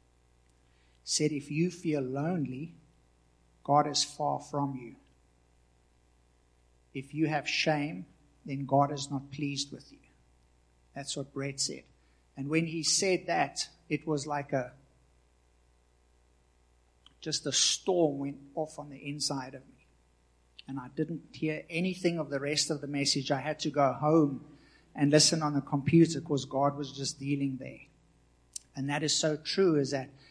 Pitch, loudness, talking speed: 140 Hz, -30 LUFS, 155 wpm